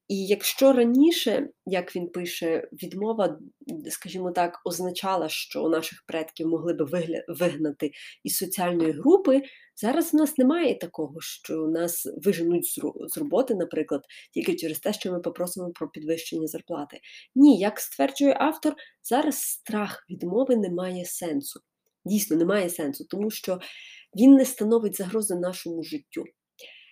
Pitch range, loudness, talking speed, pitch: 170-250 Hz, -25 LUFS, 135 wpm, 185 Hz